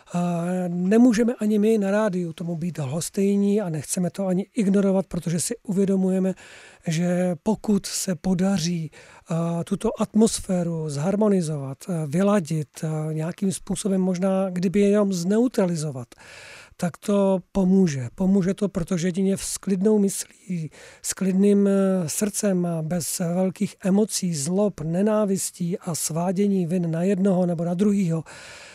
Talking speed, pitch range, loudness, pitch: 115 wpm, 175-200 Hz, -23 LUFS, 190 Hz